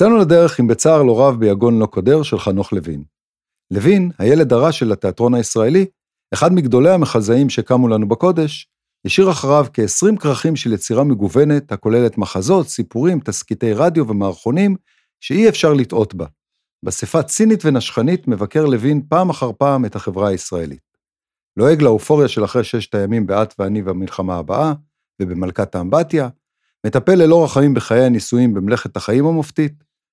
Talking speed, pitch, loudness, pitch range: 135 wpm, 125 Hz, -15 LUFS, 105-155 Hz